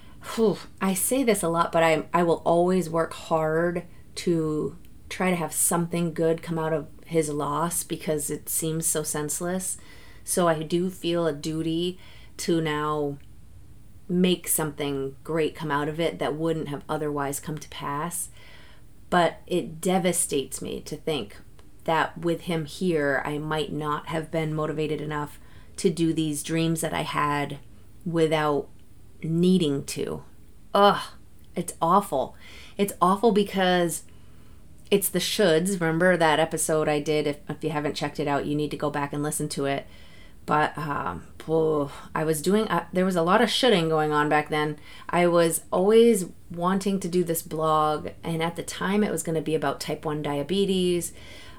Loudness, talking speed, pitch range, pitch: -25 LUFS, 165 wpm, 150-175 Hz, 160 Hz